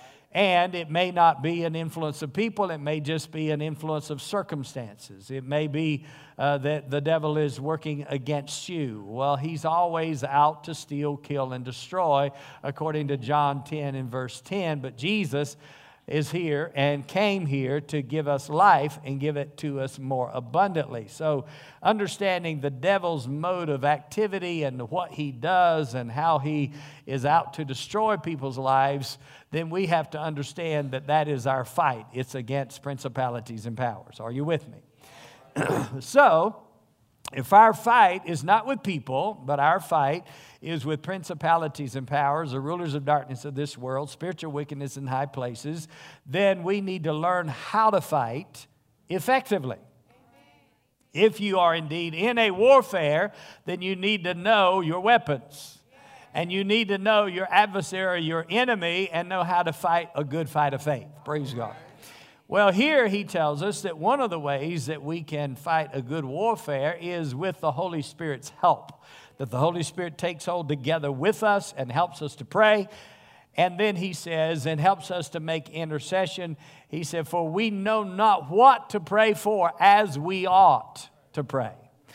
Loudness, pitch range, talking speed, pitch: -25 LUFS, 140-180 Hz, 170 wpm, 155 Hz